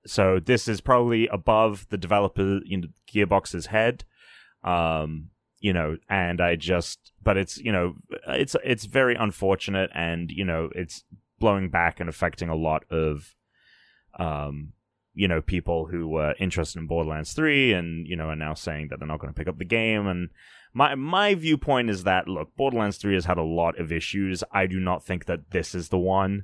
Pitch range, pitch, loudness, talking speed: 85-105 Hz, 95 Hz, -25 LUFS, 195 wpm